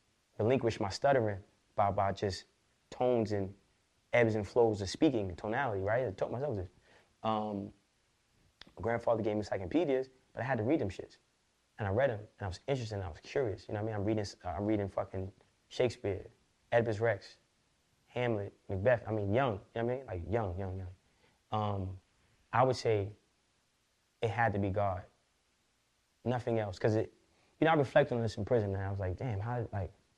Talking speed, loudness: 200 wpm, -34 LUFS